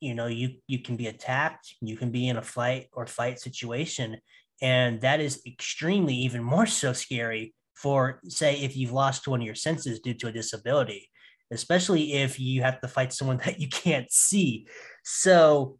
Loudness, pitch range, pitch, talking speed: -26 LUFS, 120-145 Hz, 130 Hz, 185 wpm